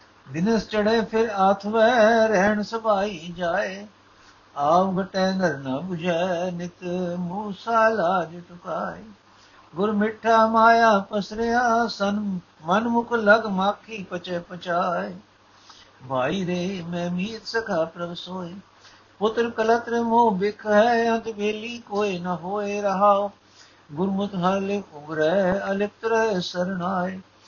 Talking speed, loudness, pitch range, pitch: 105 wpm, -23 LUFS, 180-220 Hz, 200 Hz